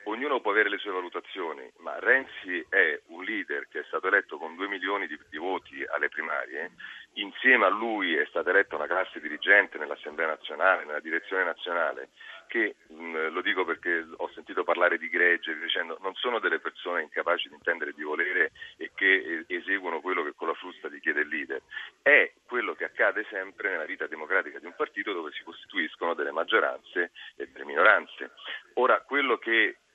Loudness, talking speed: -27 LUFS, 180 wpm